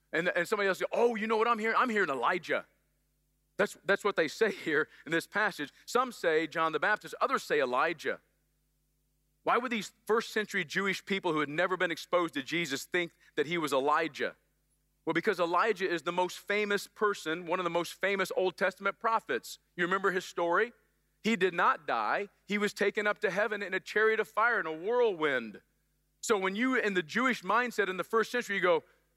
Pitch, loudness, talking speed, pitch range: 200 Hz, -31 LUFS, 210 wpm, 175-220 Hz